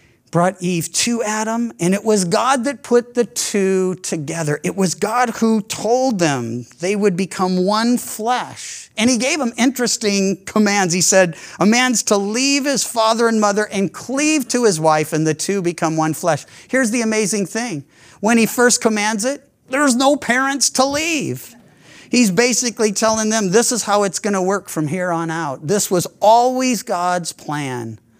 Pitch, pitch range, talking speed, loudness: 210 Hz, 180-240 Hz, 180 wpm, -17 LUFS